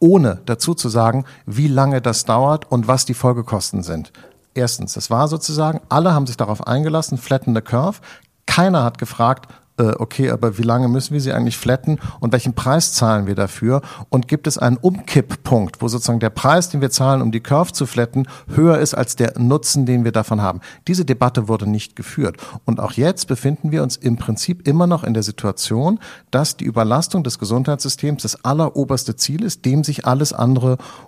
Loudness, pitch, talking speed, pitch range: -18 LUFS, 130 Hz, 190 wpm, 115-150 Hz